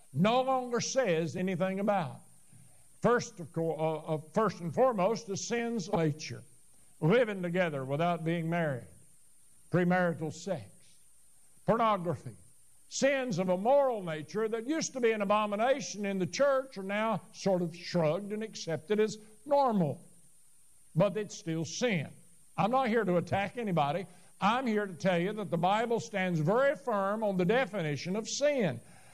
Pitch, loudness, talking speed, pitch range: 190 Hz, -31 LUFS, 150 wpm, 165-220 Hz